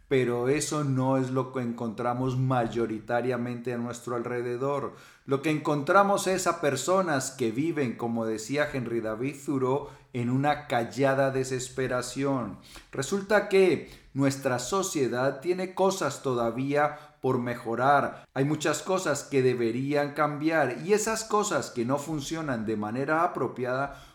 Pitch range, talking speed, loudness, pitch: 125-150 Hz, 130 wpm, -28 LUFS, 135 Hz